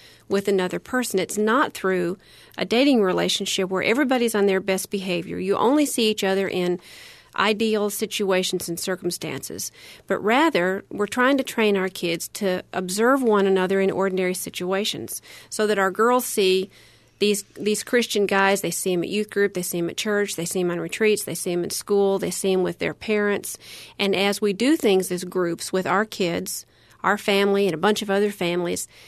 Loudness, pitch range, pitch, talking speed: -22 LUFS, 180-210 Hz, 195 Hz, 195 wpm